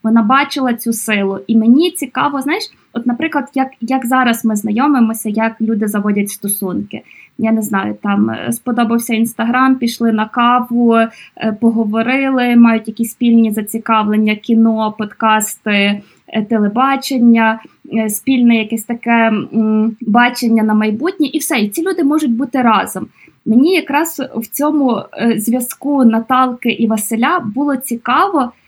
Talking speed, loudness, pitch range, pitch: 125 wpm, -14 LUFS, 220-260 Hz, 230 Hz